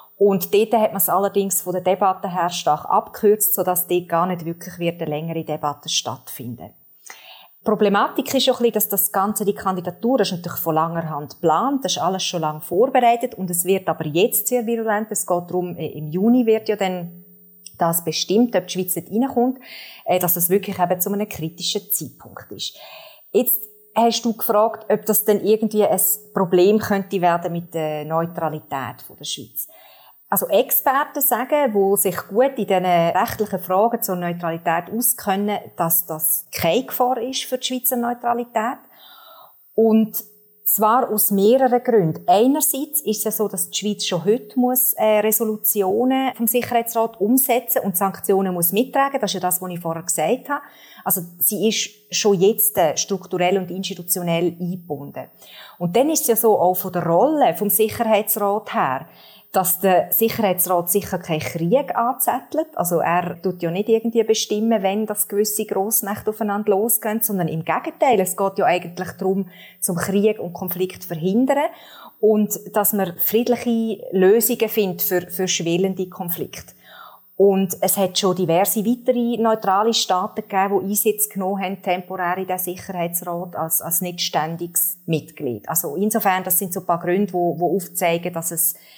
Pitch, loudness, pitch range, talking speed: 195 Hz, -20 LUFS, 180-220 Hz, 165 wpm